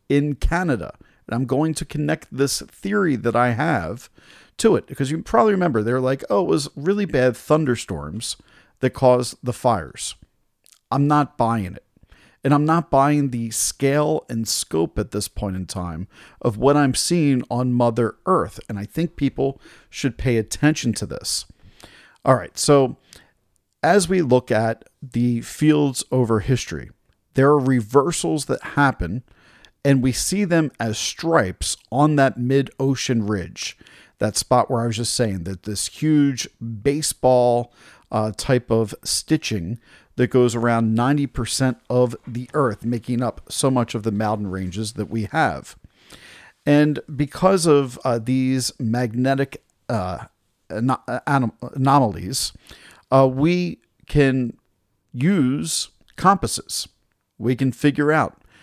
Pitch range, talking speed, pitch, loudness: 115-145 Hz, 145 wpm, 125 Hz, -21 LUFS